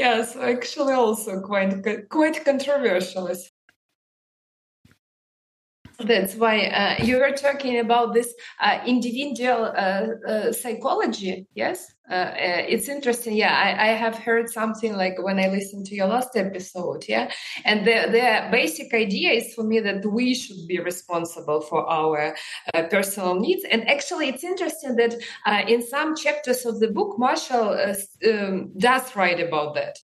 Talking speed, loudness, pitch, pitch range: 150 wpm, -23 LUFS, 225 Hz, 195-245 Hz